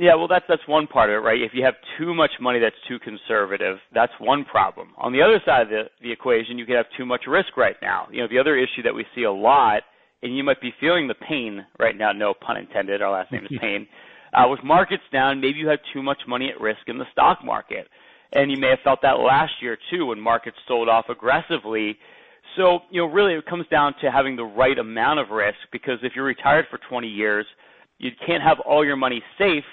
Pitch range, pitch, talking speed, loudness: 115-150 Hz, 130 Hz, 245 wpm, -21 LUFS